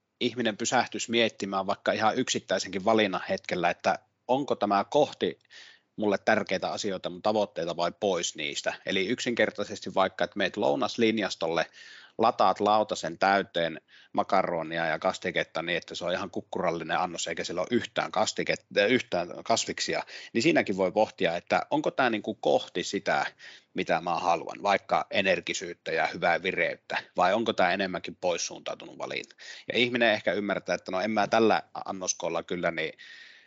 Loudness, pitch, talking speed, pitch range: -28 LUFS, 110 Hz, 145 wpm, 100-120 Hz